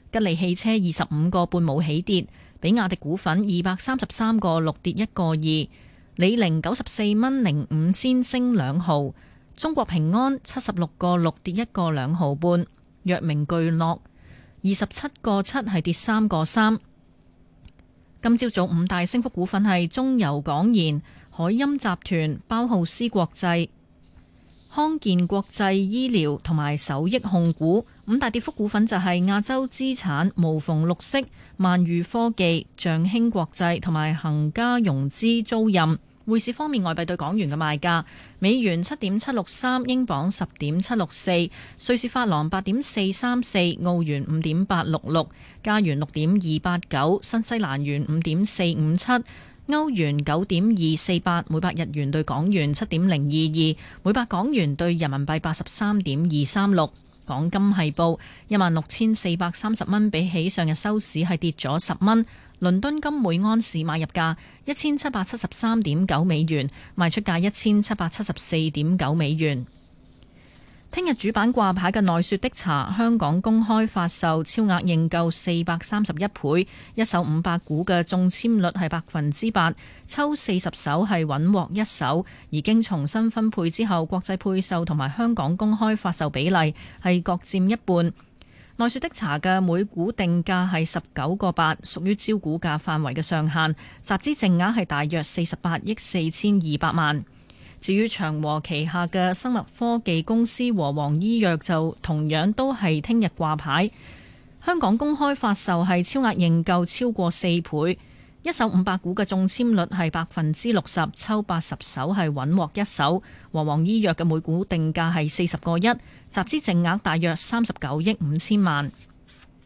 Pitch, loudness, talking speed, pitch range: 180 Hz, -23 LUFS, 250 characters per minute, 160-215 Hz